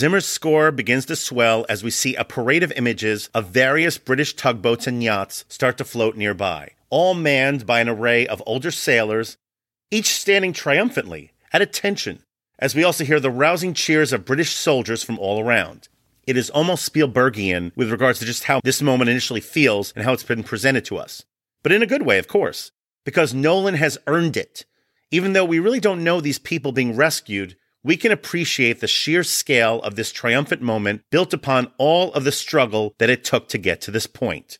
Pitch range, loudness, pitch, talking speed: 115-155 Hz, -19 LUFS, 130 Hz, 200 wpm